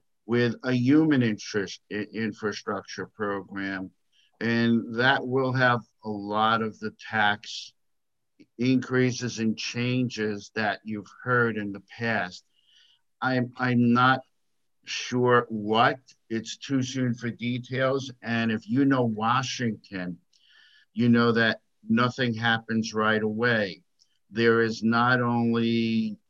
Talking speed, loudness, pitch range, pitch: 115 wpm, -26 LUFS, 110-125 Hz, 115 Hz